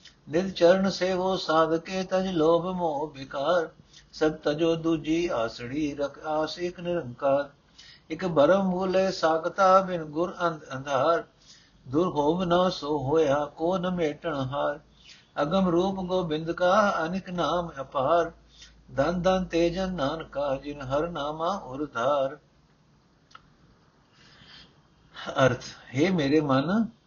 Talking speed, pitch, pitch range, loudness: 105 wpm, 165 Hz, 150-180 Hz, -26 LUFS